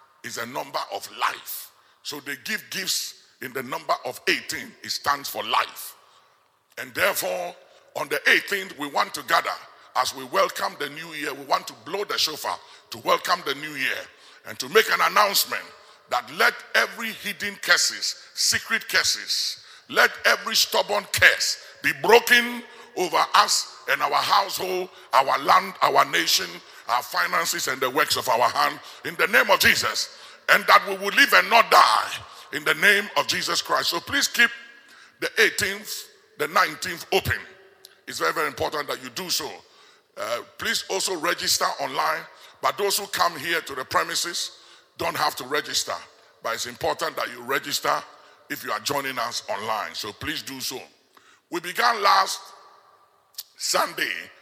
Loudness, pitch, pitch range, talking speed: -22 LUFS, 205 Hz, 185-240 Hz, 165 wpm